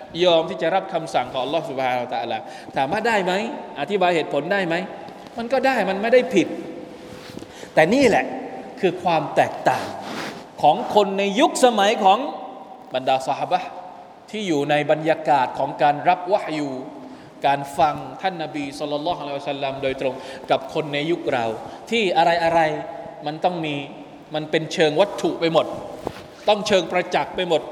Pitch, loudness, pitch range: 165 Hz, -21 LUFS, 145-195 Hz